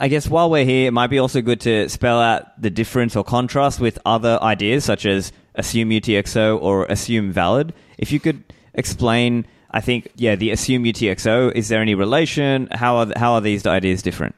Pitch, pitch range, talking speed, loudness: 115 Hz, 105-125 Hz, 200 wpm, -18 LUFS